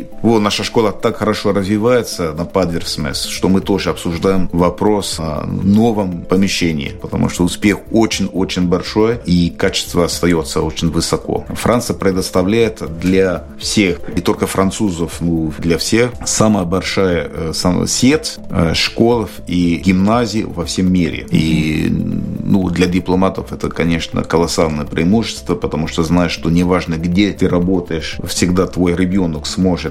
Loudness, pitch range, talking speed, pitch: -15 LUFS, 85-100 Hz, 130 wpm, 90 Hz